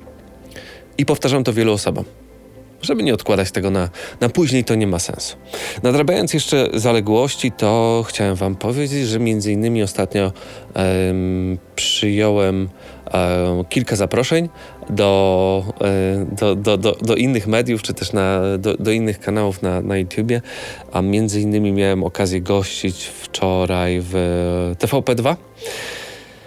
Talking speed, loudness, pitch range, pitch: 135 wpm, -18 LUFS, 95-115 Hz, 100 Hz